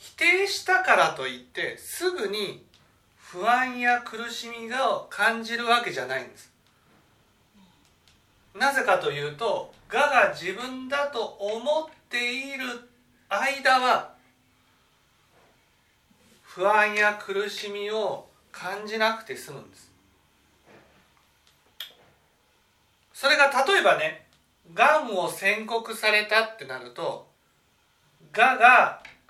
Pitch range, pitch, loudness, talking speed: 210-280 Hz, 235 Hz, -24 LUFS, 190 characters per minute